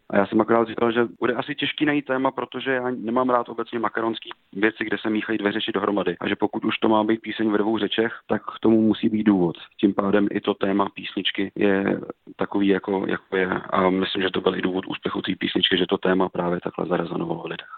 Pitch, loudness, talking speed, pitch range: 110 Hz, -23 LUFS, 235 wpm, 100-115 Hz